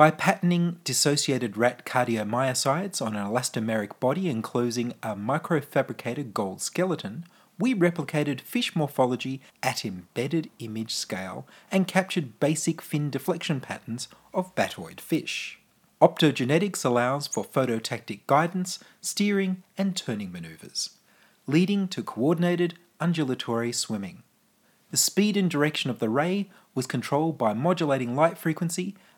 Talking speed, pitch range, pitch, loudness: 120 wpm, 125-185 Hz, 155 Hz, -27 LUFS